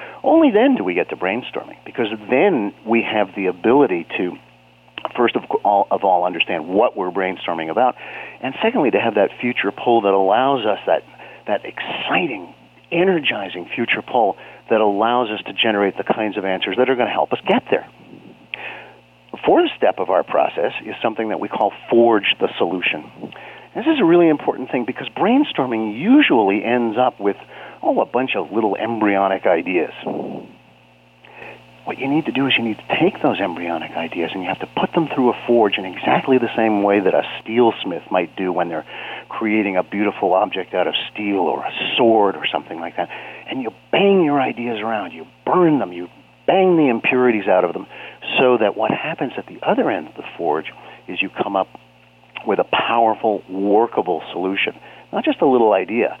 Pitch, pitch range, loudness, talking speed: 110 Hz, 95-130 Hz, -18 LUFS, 190 wpm